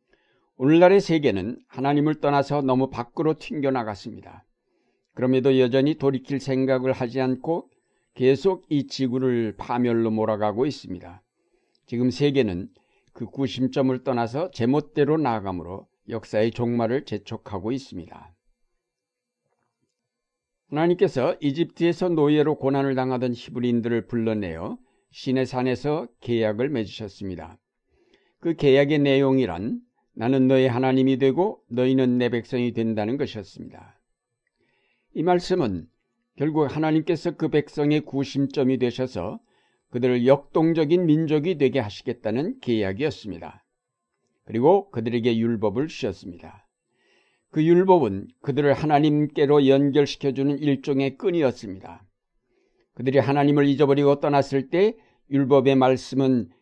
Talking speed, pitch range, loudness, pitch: 300 characters per minute, 120-145 Hz, -23 LUFS, 135 Hz